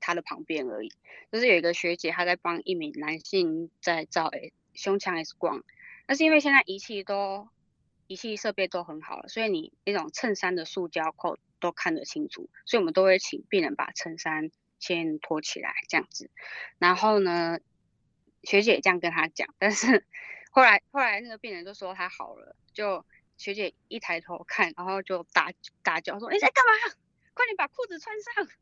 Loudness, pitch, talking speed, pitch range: -27 LUFS, 190 Hz, 270 characters per minute, 170-250 Hz